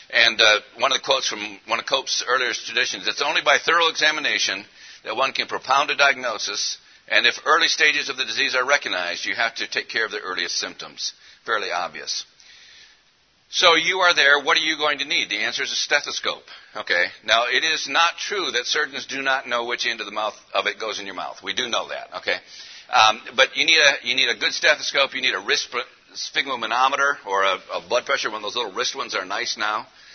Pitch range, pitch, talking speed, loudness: 135-170 Hz, 150 Hz, 230 wpm, -20 LUFS